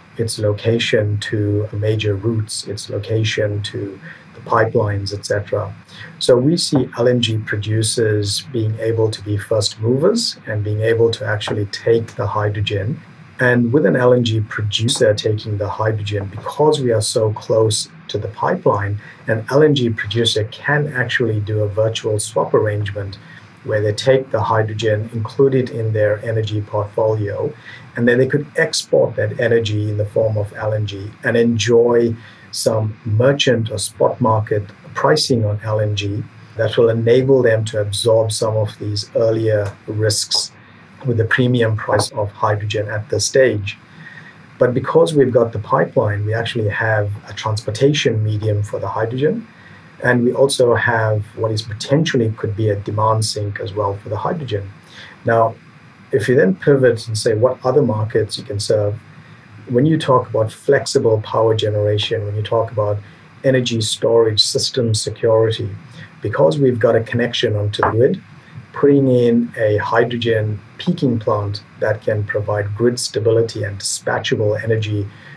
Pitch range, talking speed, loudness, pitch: 105-125 Hz, 150 wpm, -17 LUFS, 110 Hz